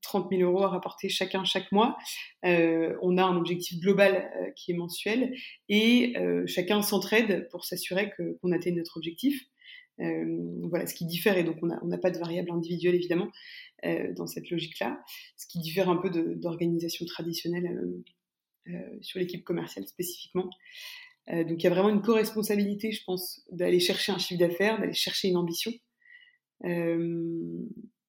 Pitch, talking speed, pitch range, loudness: 180 Hz, 175 wpm, 170-215 Hz, -29 LUFS